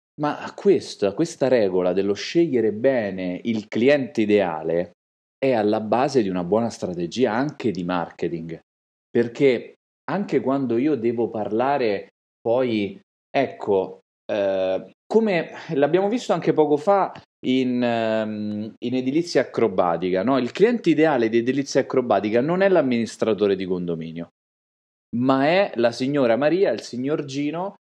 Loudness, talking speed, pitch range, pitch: -22 LUFS, 130 wpm, 105-145 Hz, 120 Hz